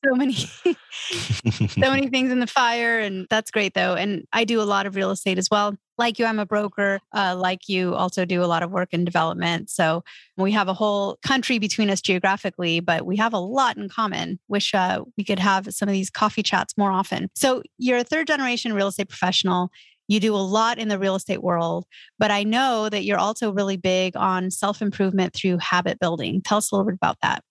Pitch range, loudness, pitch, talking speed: 185-220 Hz, -22 LUFS, 200 Hz, 225 wpm